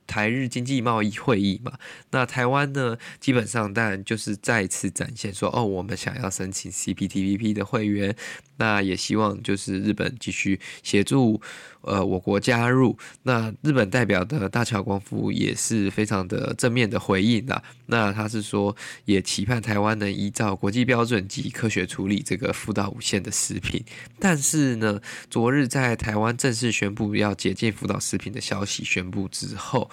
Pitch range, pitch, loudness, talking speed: 100-125 Hz, 110 Hz, -24 LUFS, 270 characters per minute